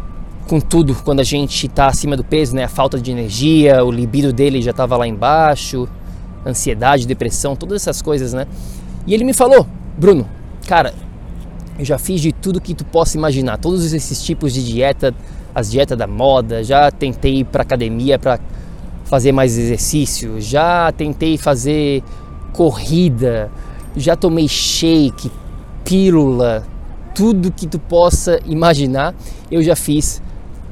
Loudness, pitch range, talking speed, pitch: -15 LUFS, 125-160 Hz, 150 wpm, 140 Hz